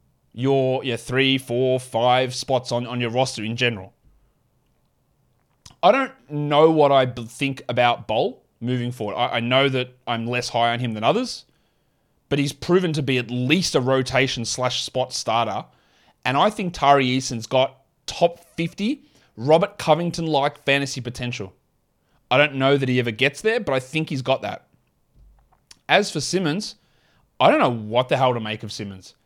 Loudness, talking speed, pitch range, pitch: -21 LUFS, 175 wpm, 120-145 Hz, 130 Hz